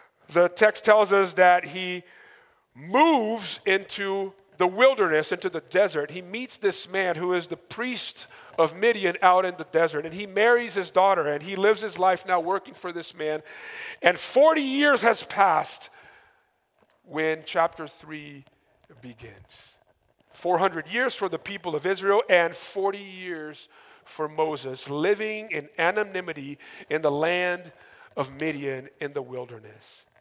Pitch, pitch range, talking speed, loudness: 180 Hz, 155-205 Hz, 145 wpm, -24 LUFS